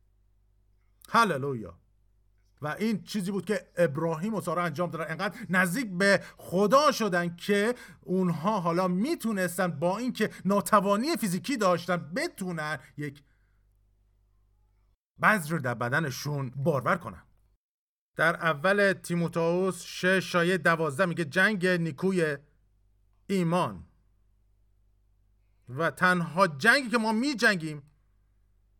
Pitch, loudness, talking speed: 170 Hz, -27 LUFS, 100 wpm